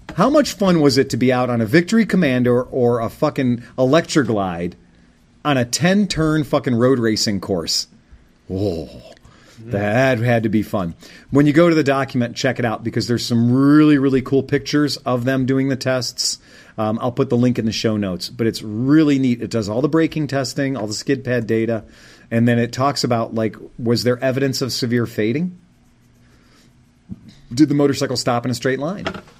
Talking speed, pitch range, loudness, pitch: 195 wpm, 115-140 Hz, -18 LUFS, 125 Hz